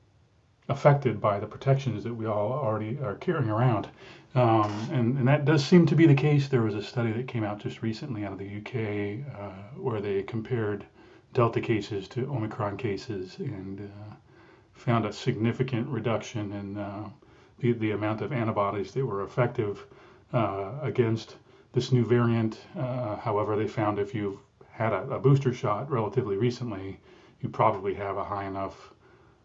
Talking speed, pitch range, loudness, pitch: 170 wpm, 105-125 Hz, -28 LUFS, 115 Hz